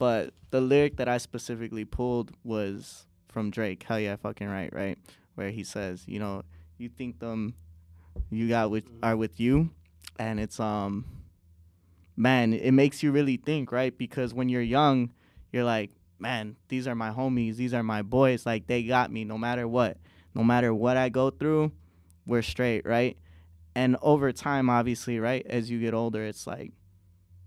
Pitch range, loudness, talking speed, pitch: 100-125 Hz, -28 LUFS, 175 wpm, 115 Hz